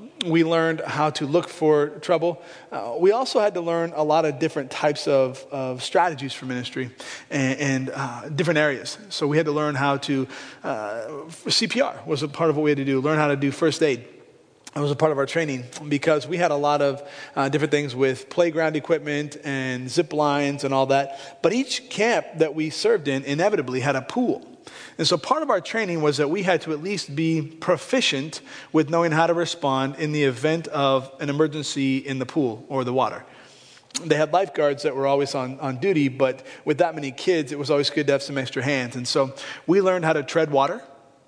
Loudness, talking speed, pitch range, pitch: -23 LUFS, 220 wpm, 135-165 Hz, 150 Hz